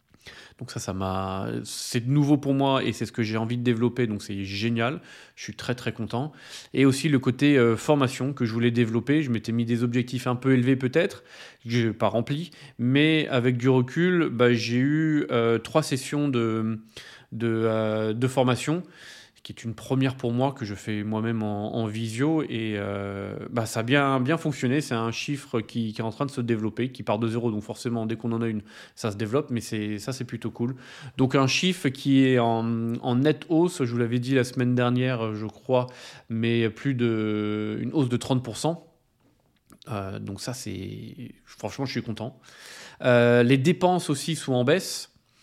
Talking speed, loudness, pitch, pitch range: 205 wpm, -25 LUFS, 120 Hz, 115-135 Hz